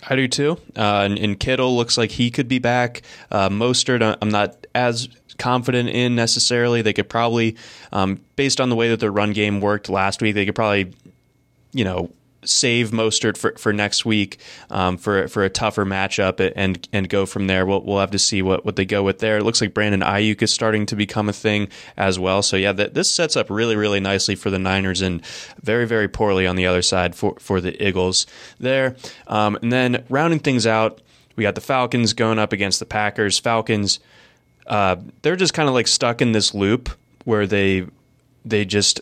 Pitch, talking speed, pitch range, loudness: 105 Hz, 210 wpm, 100-120 Hz, -19 LUFS